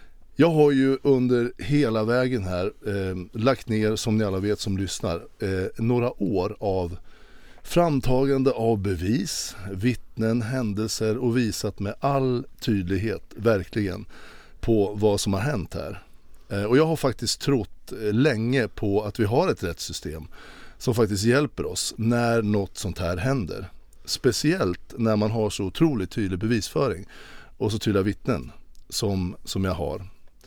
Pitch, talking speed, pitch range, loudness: 110 Hz, 150 wpm, 95-120 Hz, -25 LUFS